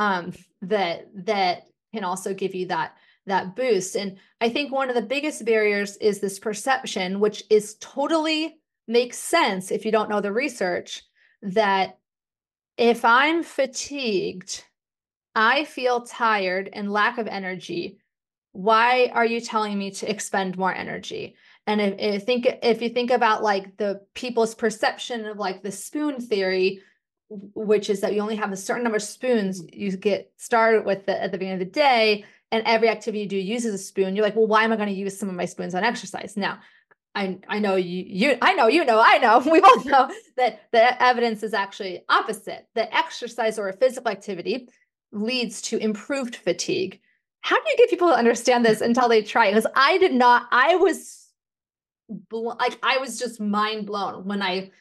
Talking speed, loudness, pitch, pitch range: 185 wpm, -22 LUFS, 220 Hz, 200-245 Hz